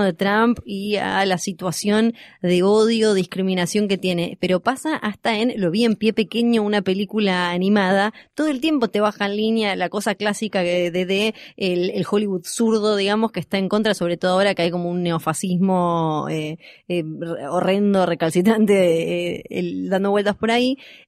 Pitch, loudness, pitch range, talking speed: 200 Hz, -20 LUFS, 180-215 Hz, 175 wpm